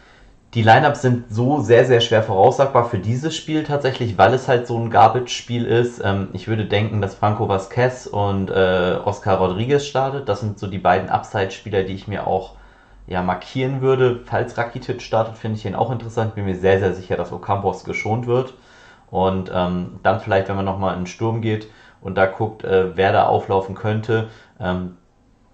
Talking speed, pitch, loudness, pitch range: 190 wpm, 110 Hz, -19 LUFS, 95-120 Hz